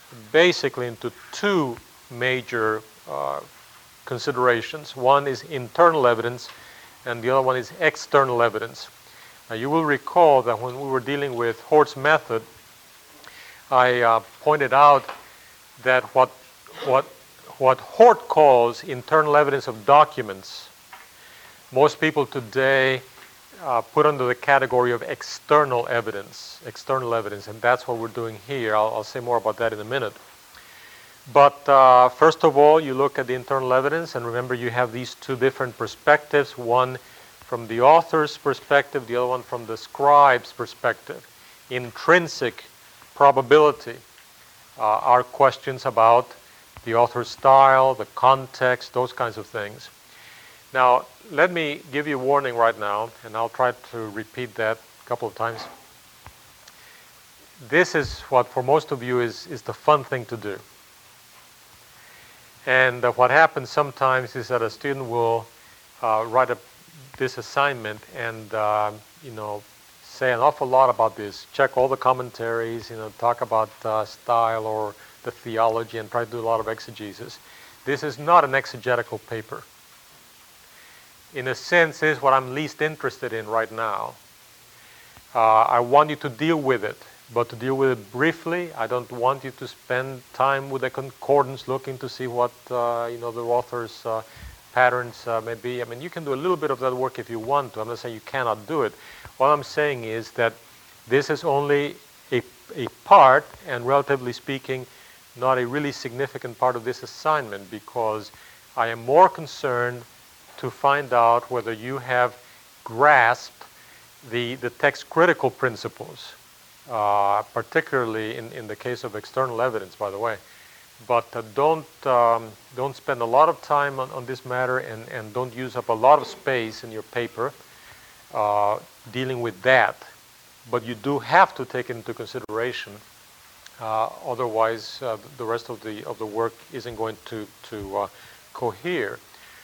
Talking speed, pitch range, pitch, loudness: 165 wpm, 115-135 Hz, 125 Hz, -22 LUFS